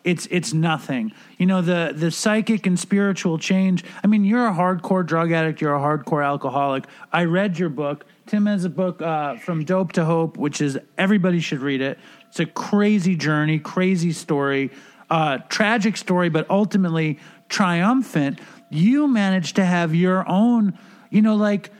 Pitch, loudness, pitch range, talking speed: 180 Hz, -21 LUFS, 160-205 Hz, 170 wpm